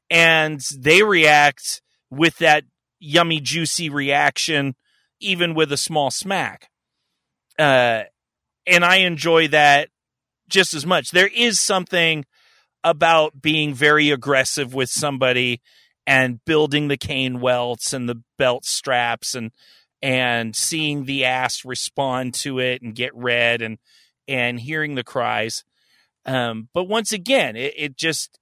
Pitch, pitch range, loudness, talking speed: 145 Hz, 125-160 Hz, -18 LUFS, 130 wpm